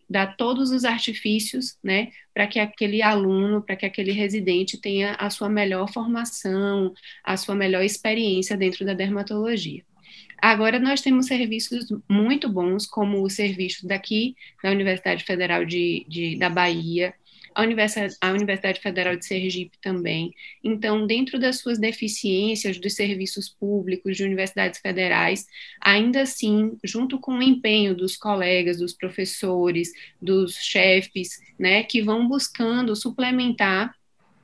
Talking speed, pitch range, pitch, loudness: 130 wpm, 190-225 Hz, 205 Hz, -23 LUFS